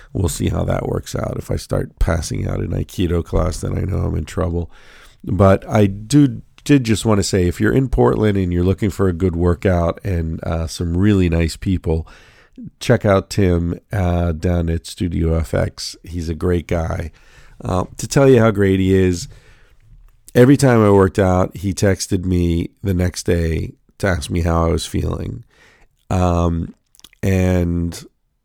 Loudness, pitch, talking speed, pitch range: -18 LUFS, 95 Hz, 180 wpm, 85-105 Hz